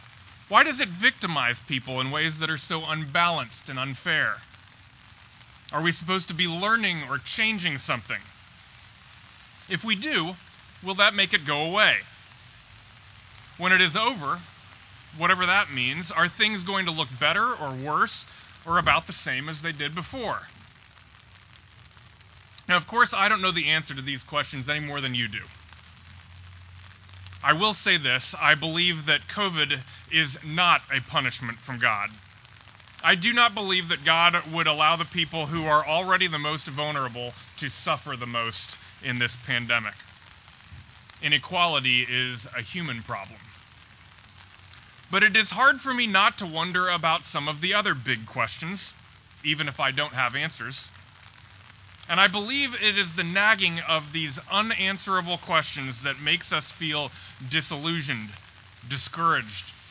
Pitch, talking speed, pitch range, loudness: 145 Hz, 150 wpm, 110-170 Hz, -24 LUFS